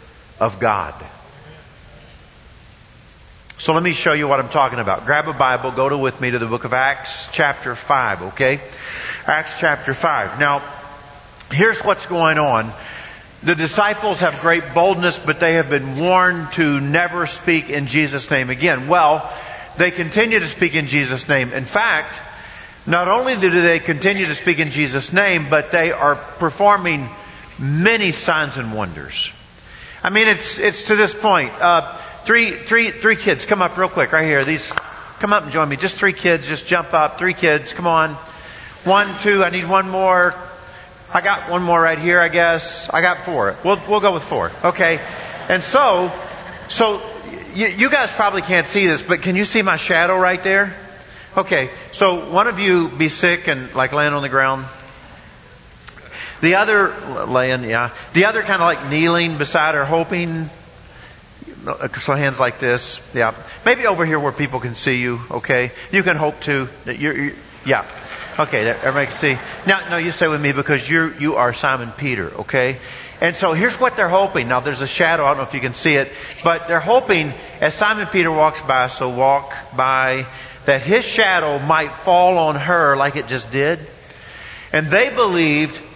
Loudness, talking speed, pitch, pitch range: -17 LUFS, 180 wpm, 160 Hz, 140-180 Hz